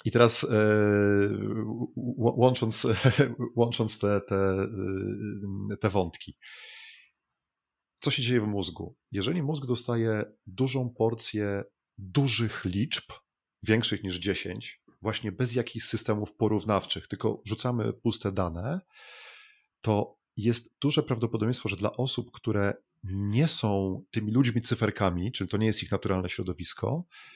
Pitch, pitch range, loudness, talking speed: 110 Hz, 100-125 Hz, -28 LUFS, 115 wpm